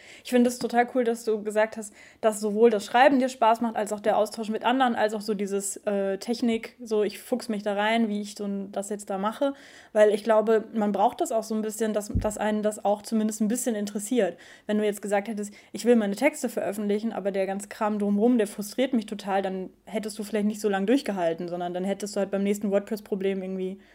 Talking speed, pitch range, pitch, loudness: 245 wpm, 205-225 Hz, 215 Hz, -26 LUFS